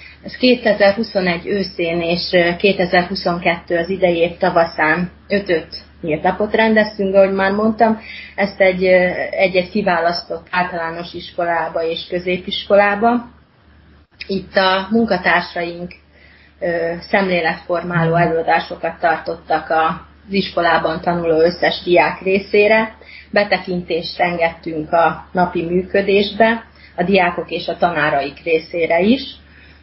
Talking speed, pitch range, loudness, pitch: 95 wpm, 165-195 Hz, -17 LUFS, 175 Hz